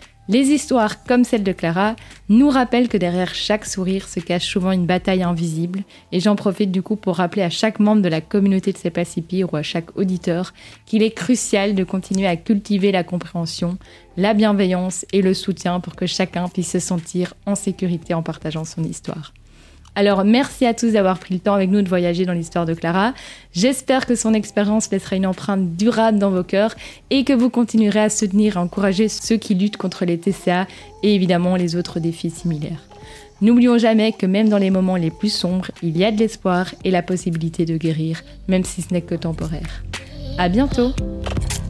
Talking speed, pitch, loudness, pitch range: 200 wpm, 190 Hz, -19 LUFS, 175-210 Hz